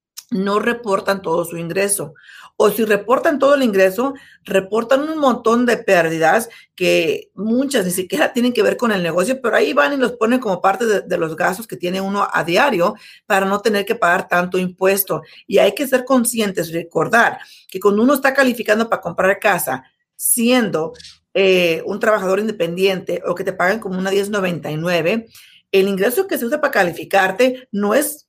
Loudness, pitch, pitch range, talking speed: -17 LUFS, 205 Hz, 185-245 Hz, 180 wpm